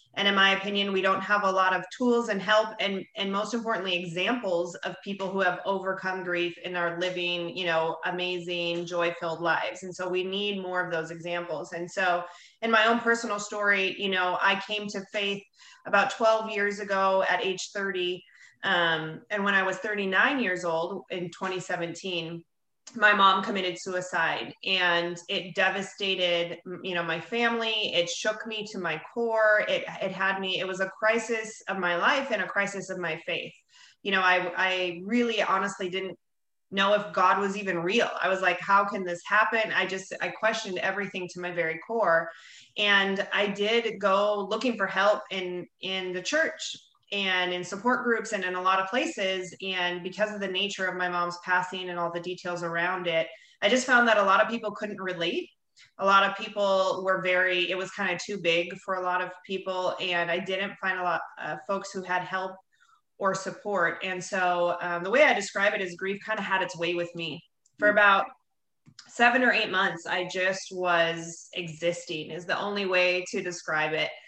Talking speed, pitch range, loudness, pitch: 195 wpm, 180-200 Hz, -27 LUFS, 190 Hz